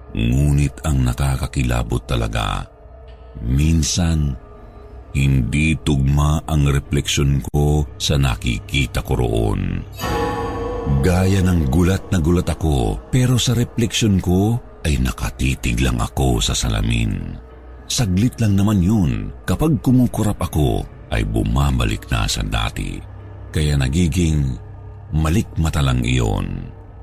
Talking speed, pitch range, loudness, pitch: 105 wpm, 70-100 Hz, -19 LUFS, 80 Hz